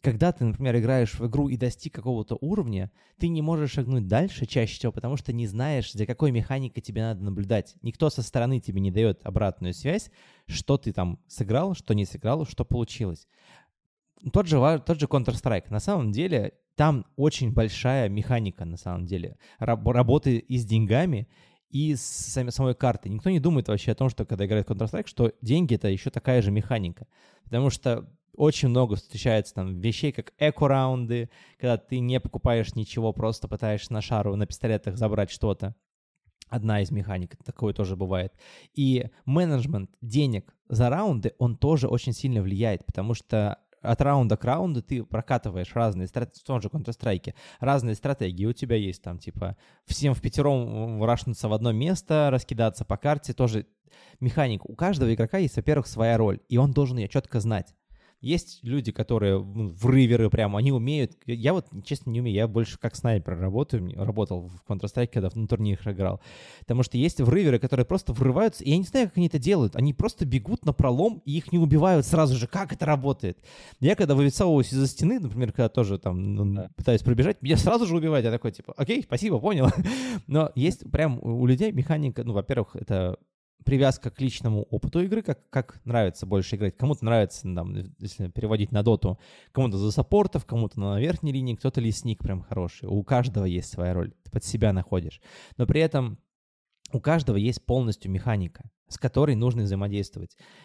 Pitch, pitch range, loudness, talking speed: 120 Hz, 105-140 Hz, -26 LUFS, 180 wpm